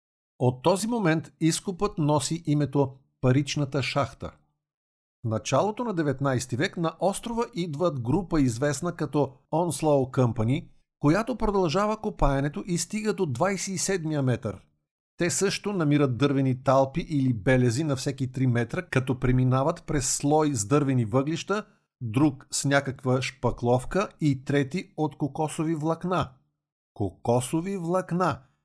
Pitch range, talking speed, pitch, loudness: 130-175 Hz, 120 wpm, 145 Hz, -26 LUFS